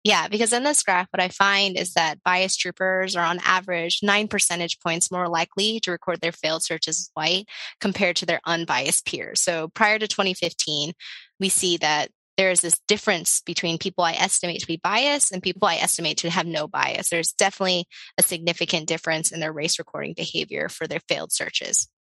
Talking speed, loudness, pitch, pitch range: 195 wpm, -22 LUFS, 175 Hz, 165-190 Hz